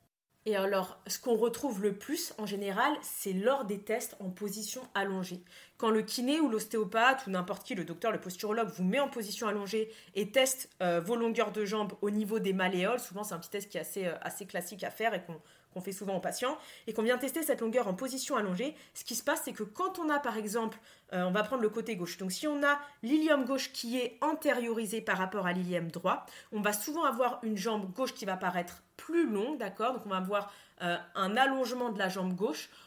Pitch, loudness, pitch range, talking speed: 215 Hz, -33 LUFS, 190-255 Hz, 235 wpm